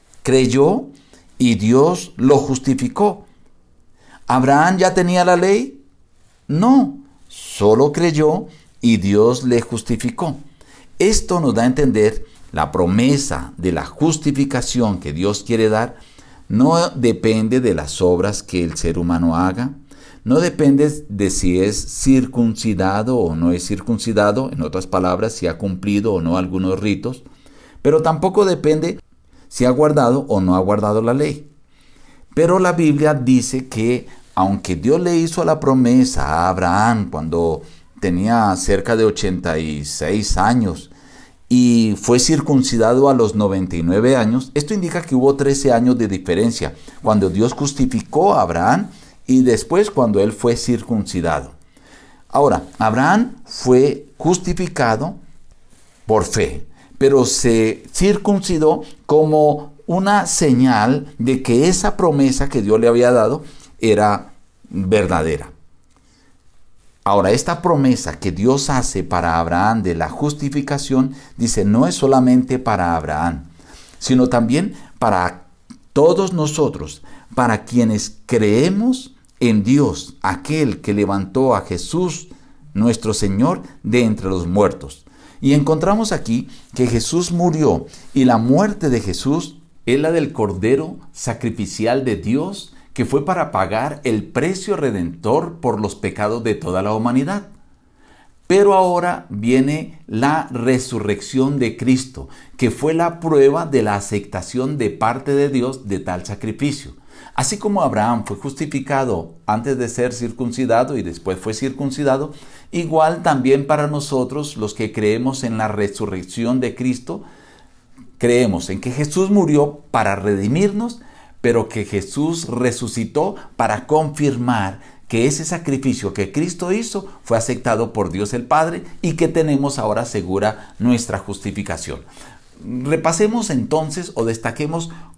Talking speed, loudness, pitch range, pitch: 130 wpm, -17 LUFS, 105-145 Hz, 125 Hz